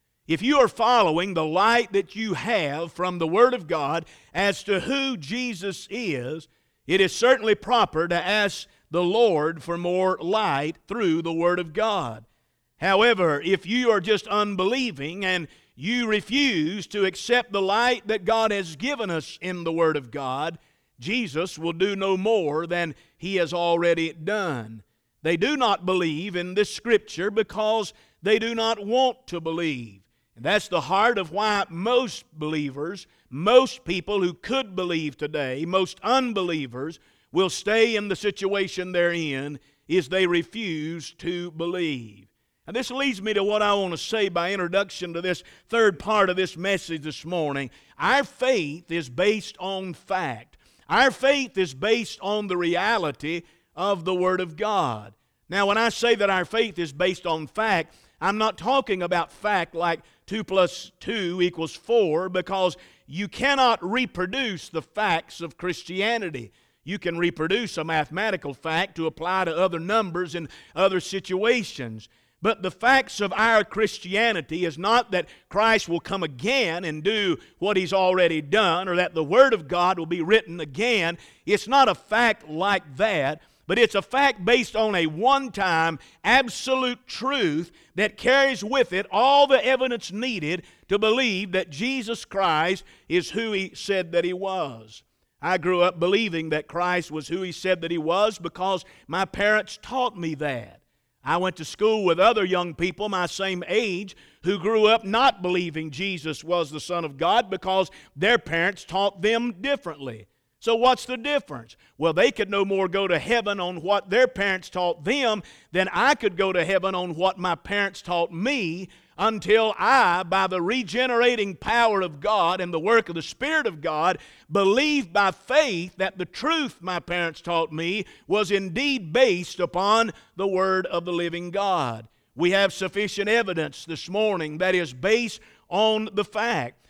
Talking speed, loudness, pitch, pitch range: 170 wpm, -24 LUFS, 185 Hz, 170-215 Hz